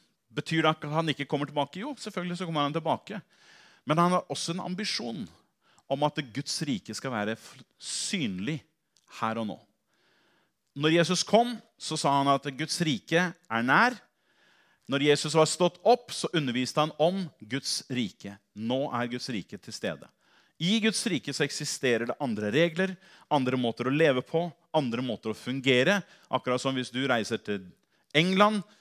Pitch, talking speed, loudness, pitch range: 150 Hz, 170 wpm, -28 LUFS, 125-170 Hz